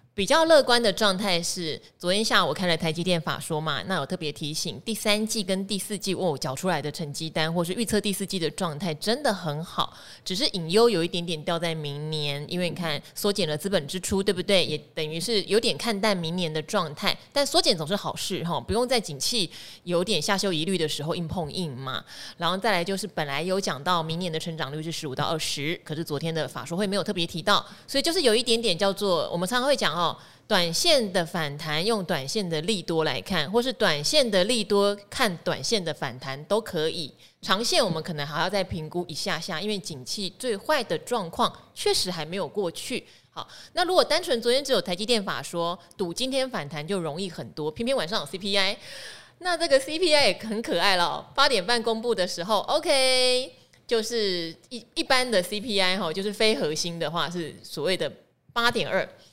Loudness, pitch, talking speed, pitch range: -25 LUFS, 185 Hz, 315 characters per minute, 160-220 Hz